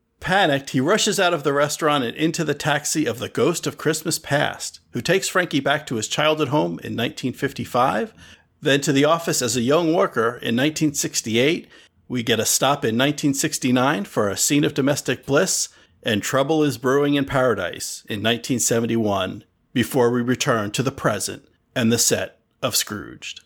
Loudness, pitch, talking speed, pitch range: -21 LUFS, 140 Hz, 175 wpm, 120-150 Hz